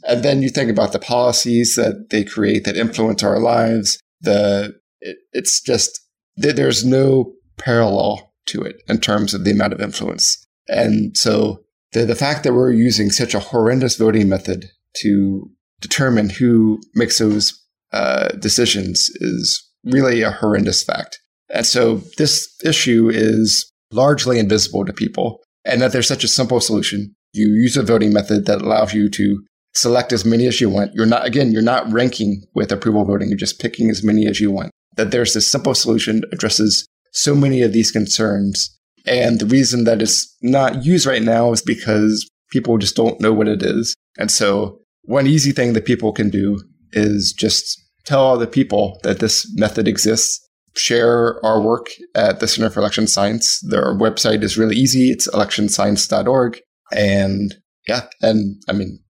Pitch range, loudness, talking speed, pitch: 105-120 Hz, -16 LUFS, 175 wpm, 110 Hz